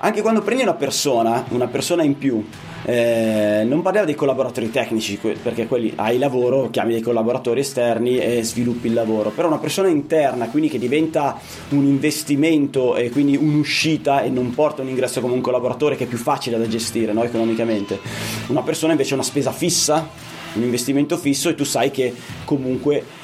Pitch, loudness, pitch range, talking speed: 130 Hz, -19 LUFS, 115-150 Hz, 185 wpm